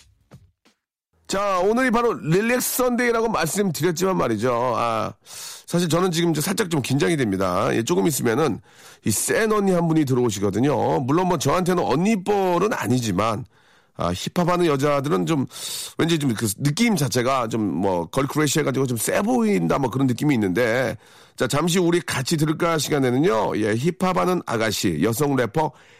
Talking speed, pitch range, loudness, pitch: 335 characters per minute, 135-185 Hz, -21 LUFS, 160 Hz